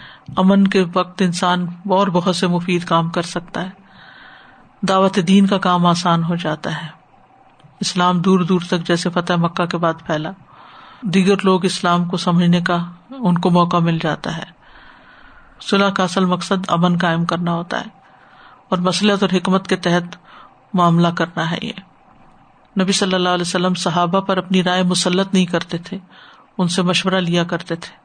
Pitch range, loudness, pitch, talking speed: 175-195 Hz, -17 LUFS, 180 Hz, 170 wpm